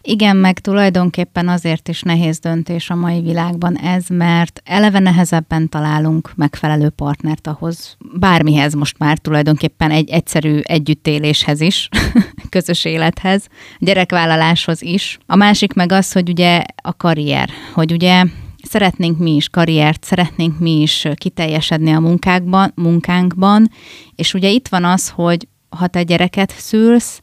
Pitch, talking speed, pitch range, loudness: 170 Hz, 135 wpm, 160-180 Hz, -14 LUFS